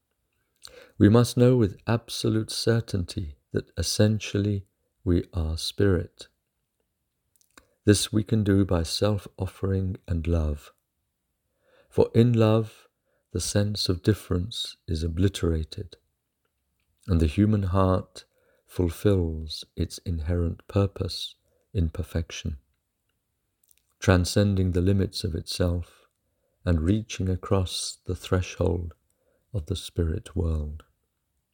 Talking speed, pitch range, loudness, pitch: 100 wpm, 85-105 Hz, -26 LUFS, 95 Hz